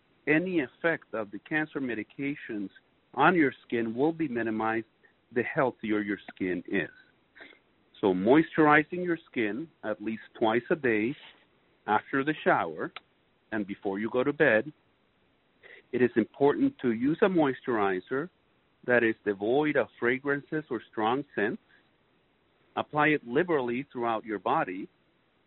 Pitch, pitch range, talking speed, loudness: 130 Hz, 110-155 Hz, 130 wpm, -28 LUFS